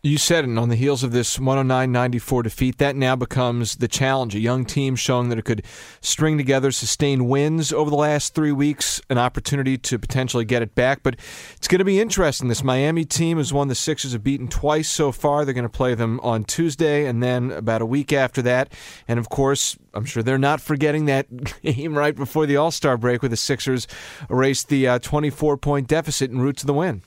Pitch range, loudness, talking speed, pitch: 125-145 Hz, -21 LUFS, 215 wpm, 135 Hz